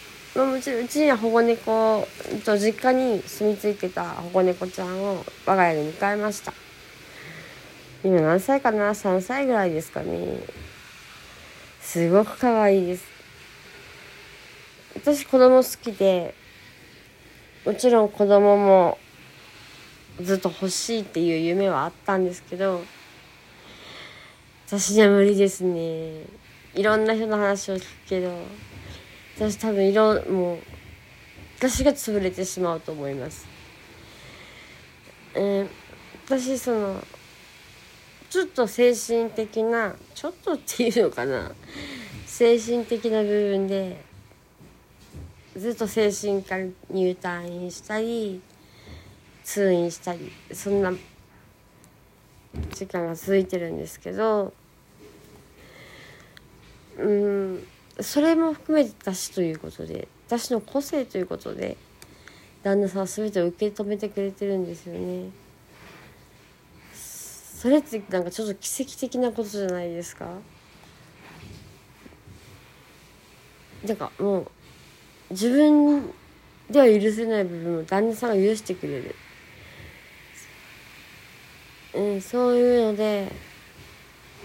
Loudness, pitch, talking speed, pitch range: -23 LUFS, 200 Hz, 210 characters per minute, 180-230 Hz